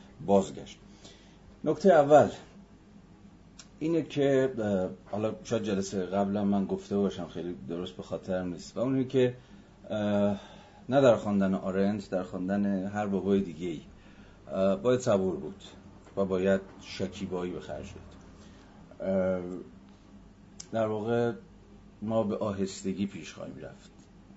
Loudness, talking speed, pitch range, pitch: -29 LUFS, 115 wpm, 95-105 Hz, 100 Hz